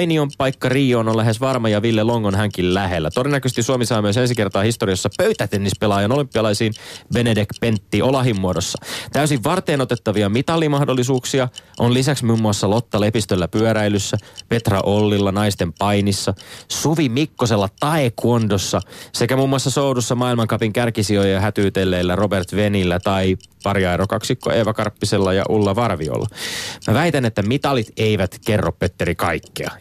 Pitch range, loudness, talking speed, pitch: 100-125 Hz, -19 LUFS, 140 wpm, 110 Hz